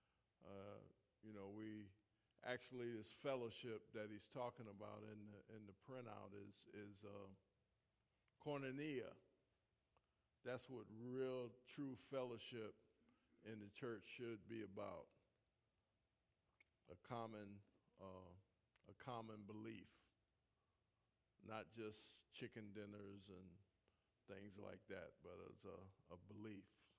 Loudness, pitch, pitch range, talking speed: -56 LUFS, 110 Hz, 100-115 Hz, 110 wpm